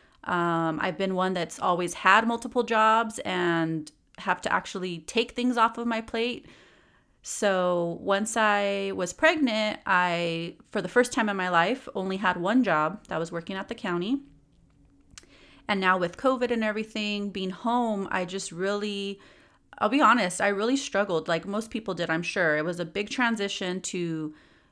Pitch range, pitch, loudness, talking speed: 180-225 Hz, 195 Hz, -26 LUFS, 170 wpm